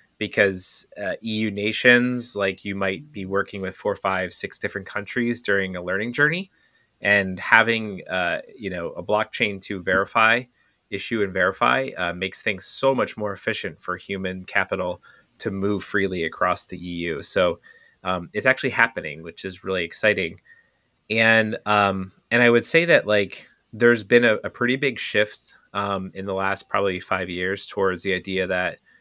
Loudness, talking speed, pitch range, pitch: -22 LUFS, 170 wpm, 95-115 Hz, 100 Hz